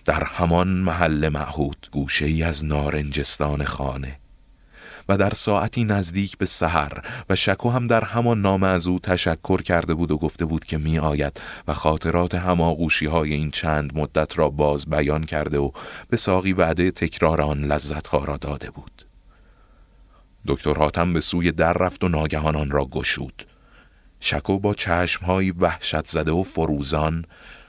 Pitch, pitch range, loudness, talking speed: 80 Hz, 75-95 Hz, -21 LUFS, 155 wpm